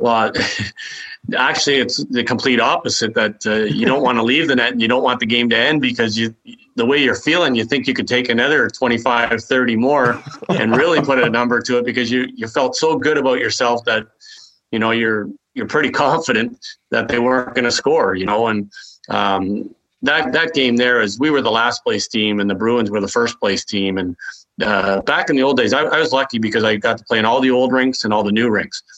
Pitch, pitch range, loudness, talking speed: 120 Hz, 110-130 Hz, -16 LUFS, 240 wpm